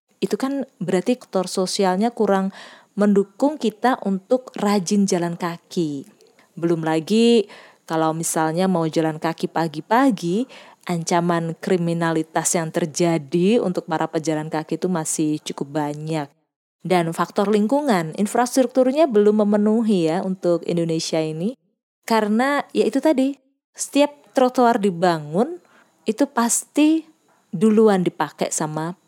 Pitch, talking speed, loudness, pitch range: 190 Hz, 110 wpm, -21 LUFS, 165-235 Hz